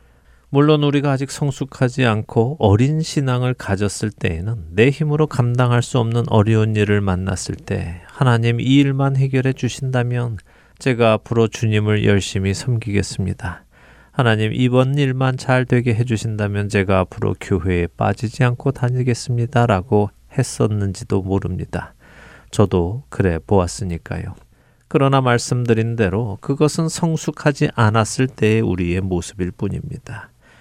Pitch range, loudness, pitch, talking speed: 100-130 Hz, -18 LUFS, 115 Hz, 310 characters per minute